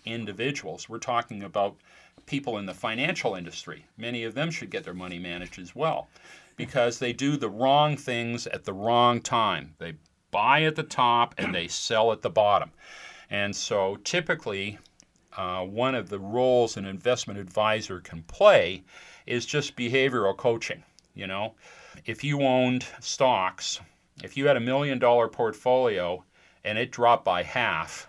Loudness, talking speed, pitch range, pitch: -26 LUFS, 160 wpm, 100-130 Hz, 120 Hz